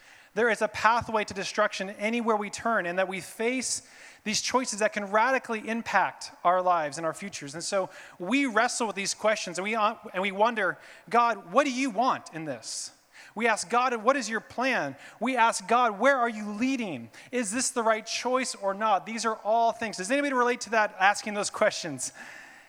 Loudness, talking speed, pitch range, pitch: -27 LUFS, 200 wpm, 200-240 Hz, 220 Hz